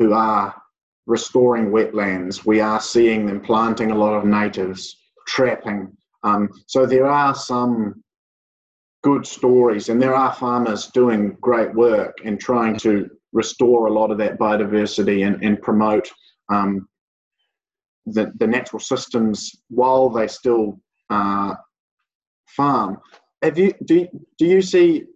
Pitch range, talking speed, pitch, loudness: 105-125 Hz, 135 wpm, 110 Hz, -19 LUFS